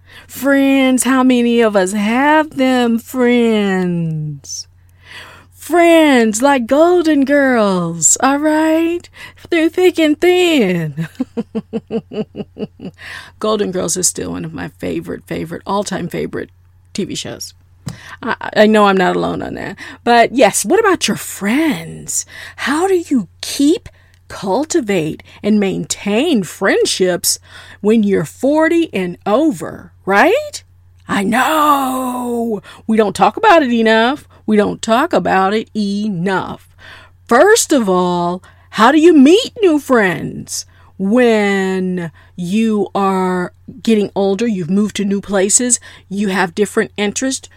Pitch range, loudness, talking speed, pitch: 185-270 Hz, -14 LUFS, 120 wpm, 215 Hz